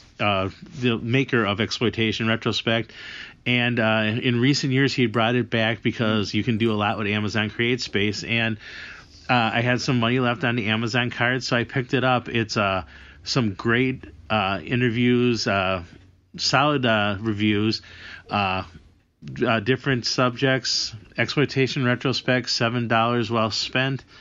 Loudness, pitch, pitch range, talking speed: -22 LUFS, 115 Hz, 105-125 Hz, 150 wpm